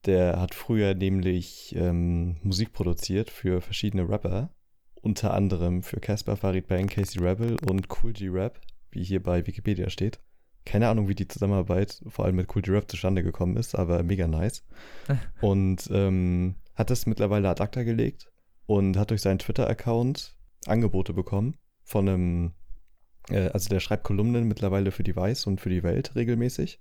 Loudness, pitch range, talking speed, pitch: -27 LUFS, 90-110 Hz, 165 wpm, 95 Hz